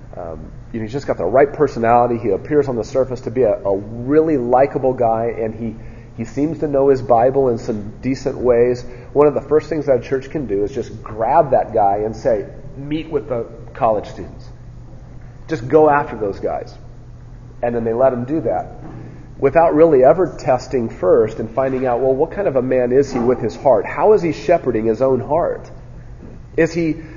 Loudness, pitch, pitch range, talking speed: -17 LUFS, 125 Hz, 120-145 Hz, 210 wpm